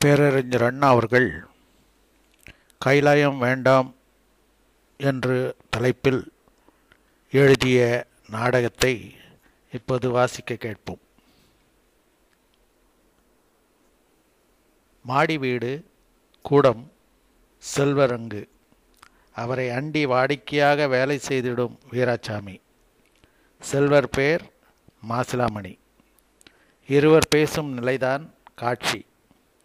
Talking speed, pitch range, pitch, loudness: 60 wpm, 120-140 Hz, 125 Hz, -22 LUFS